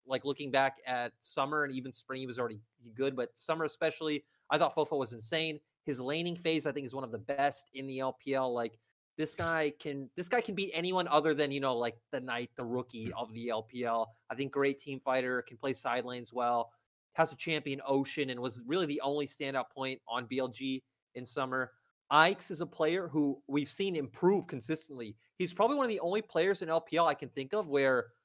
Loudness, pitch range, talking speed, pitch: -34 LUFS, 125-155 Hz, 215 wpm, 135 Hz